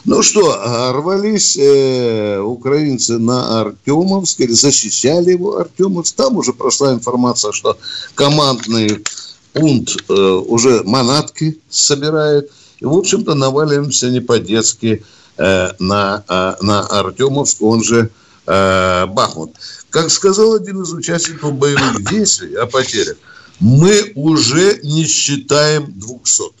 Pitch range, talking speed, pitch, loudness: 110-155 Hz, 115 wpm, 135 Hz, -13 LUFS